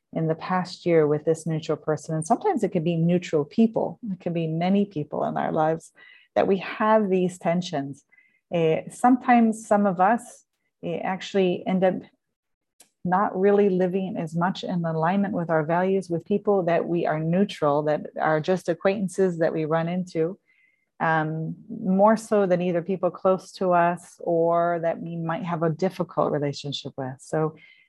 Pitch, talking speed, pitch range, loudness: 180 Hz, 170 wpm, 160-195 Hz, -24 LUFS